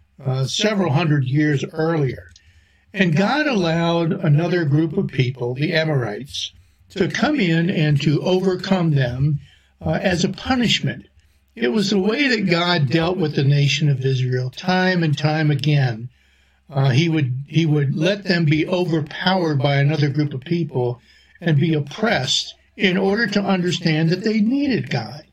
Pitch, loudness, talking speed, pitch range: 155 Hz, -19 LUFS, 155 wpm, 140-185 Hz